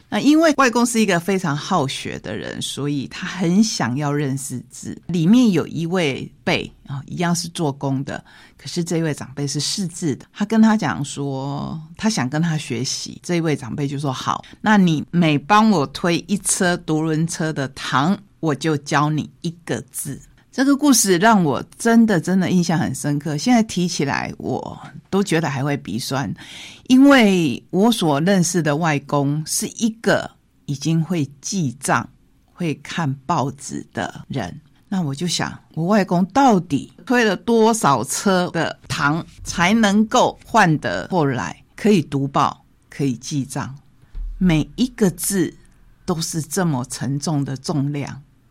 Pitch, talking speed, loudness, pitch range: 160 Hz, 225 characters per minute, -19 LUFS, 140-195 Hz